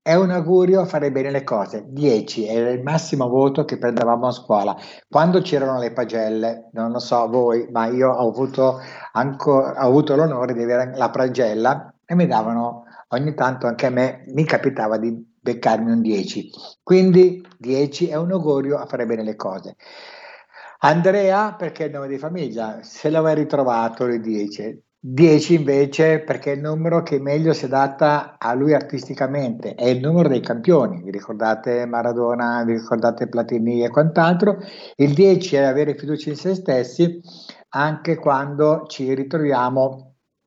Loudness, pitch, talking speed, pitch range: -19 LUFS, 135 Hz, 165 wpm, 120-155 Hz